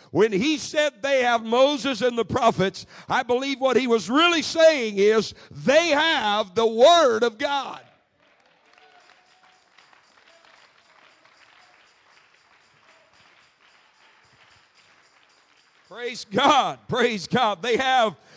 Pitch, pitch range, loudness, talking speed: 250 Hz, 225-285 Hz, -21 LUFS, 95 wpm